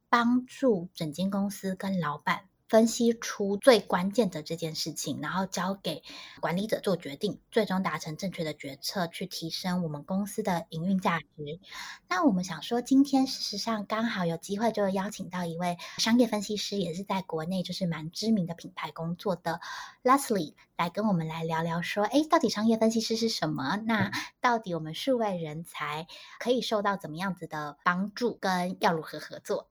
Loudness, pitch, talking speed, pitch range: -29 LUFS, 190 Hz, 290 characters per minute, 165-220 Hz